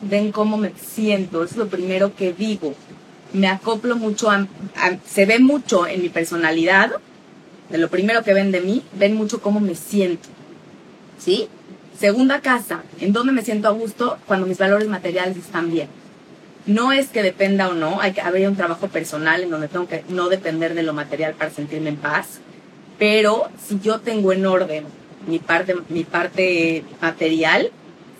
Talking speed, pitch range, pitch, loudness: 180 wpm, 170-210 Hz, 190 Hz, -19 LUFS